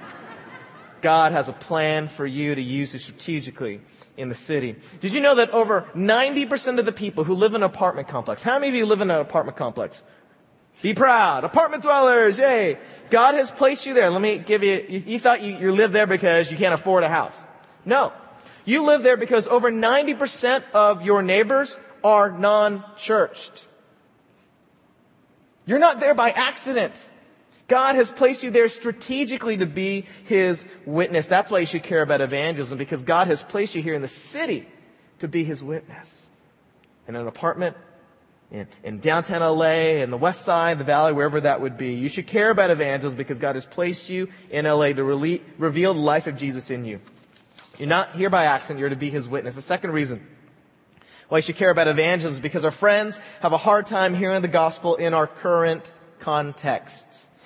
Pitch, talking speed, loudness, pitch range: 175 Hz, 190 wpm, -21 LUFS, 155-220 Hz